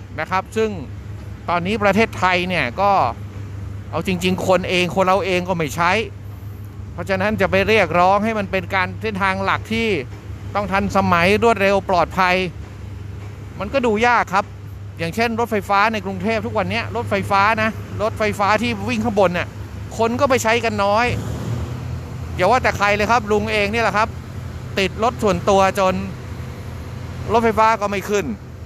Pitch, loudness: 185 Hz, -18 LUFS